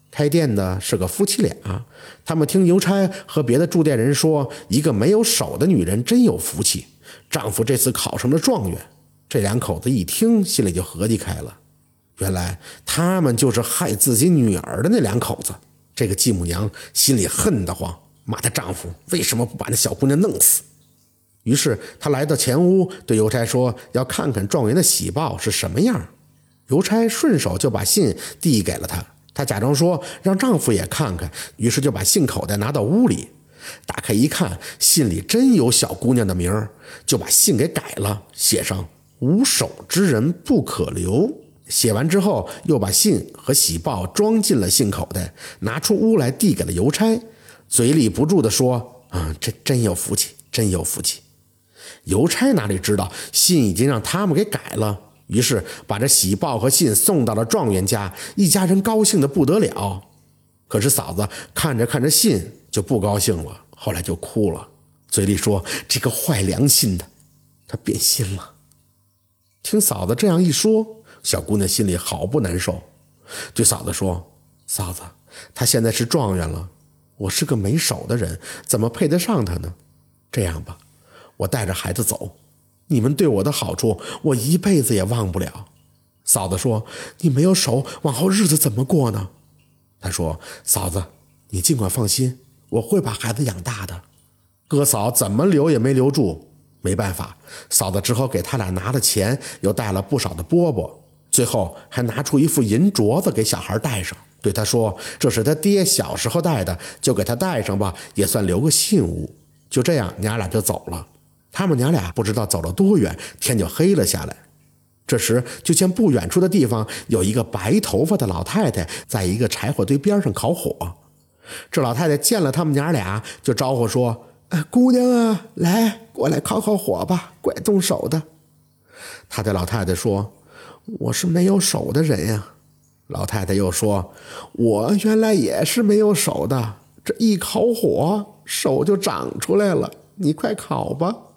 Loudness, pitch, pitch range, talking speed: -19 LUFS, 120 Hz, 100-160 Hz, 250 characters per minute